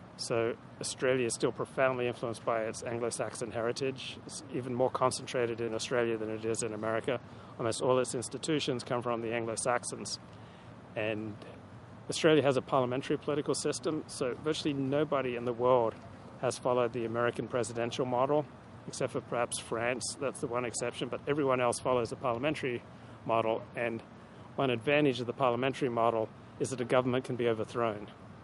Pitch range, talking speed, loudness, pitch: 115-130 Hz, 160 wpm, -32 LUFS, 120 Hz